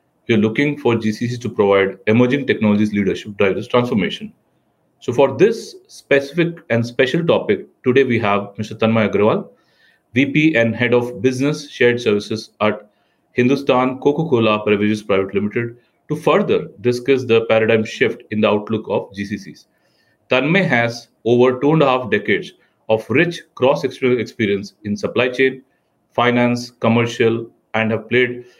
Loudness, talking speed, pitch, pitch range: -17 LUFS, 145 wpm, 120 Hz, 110-130 Hz